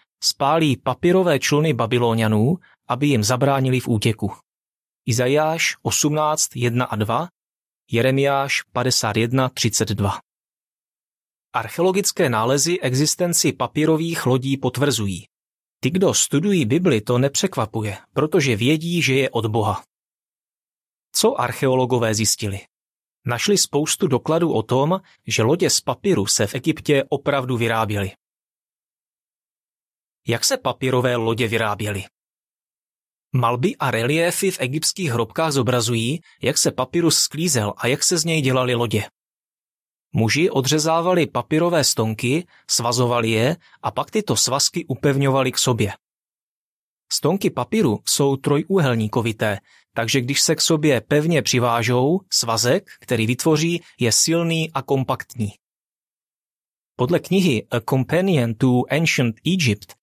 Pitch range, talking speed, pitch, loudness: 115-155 Hz, 110 wpm, 130 Hz, -20 LUFS